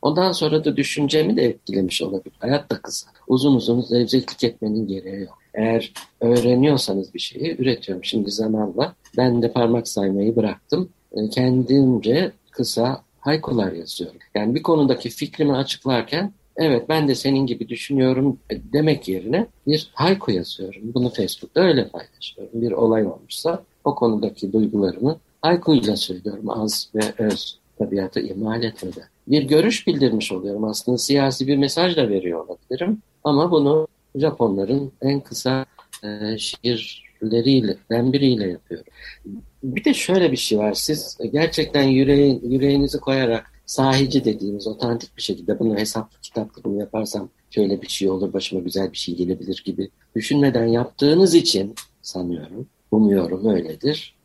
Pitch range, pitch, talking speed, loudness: 105-140 Hz, 120 Hz, 135 wpm, -21 LUFS